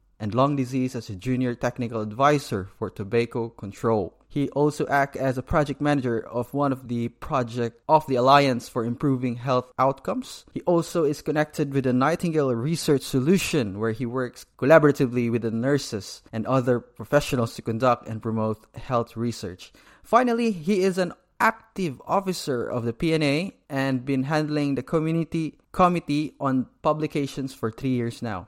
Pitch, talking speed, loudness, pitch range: 130 Hz, 160 wpm, -24 LUFS, 120-150 Hz